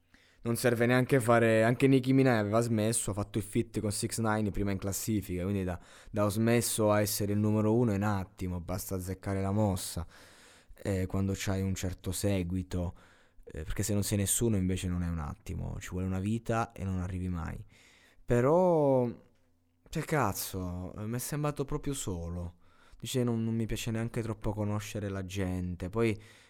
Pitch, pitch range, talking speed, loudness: 105 Hz, 95-115 Hz, 185 wpm, -31 LUFS